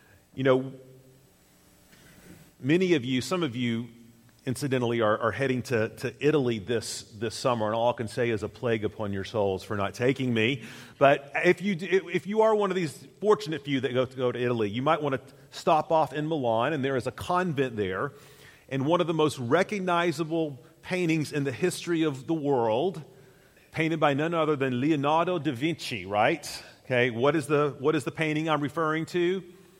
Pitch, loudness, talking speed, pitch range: 140 Hz, -27 LUFS, 195 wpm, 120-160 Hz